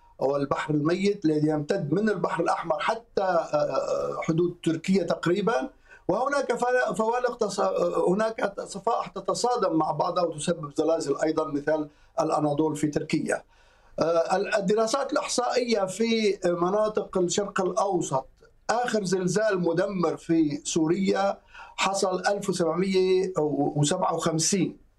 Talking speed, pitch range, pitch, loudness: 95 wpm, 160-205 Hz, 180 Hz, -26 LUFS